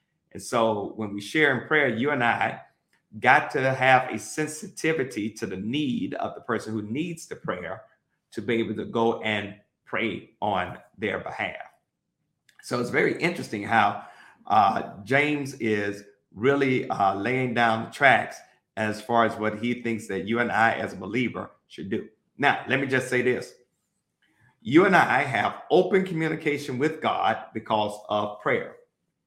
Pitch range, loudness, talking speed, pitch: 110-145 Hz, -25 LUFS, 165 wpm, 120 Hz